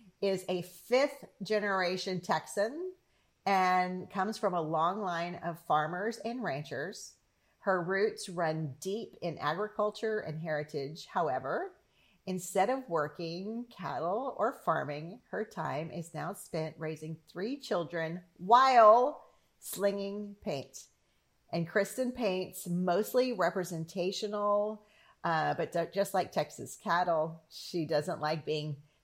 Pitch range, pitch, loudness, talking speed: 165-210 Hz, 185 Hz, -33 LUFS, 120 wpm